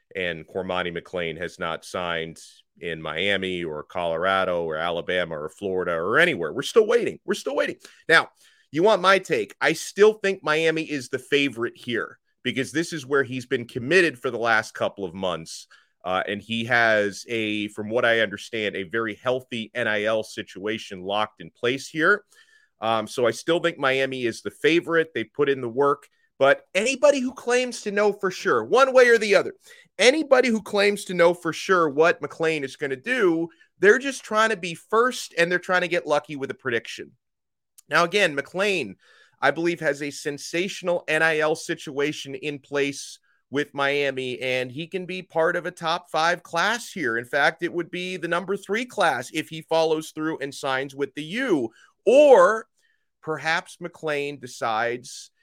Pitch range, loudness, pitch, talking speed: 130-200 Hz, -23 LUFS, 160 Hz, 180 wpm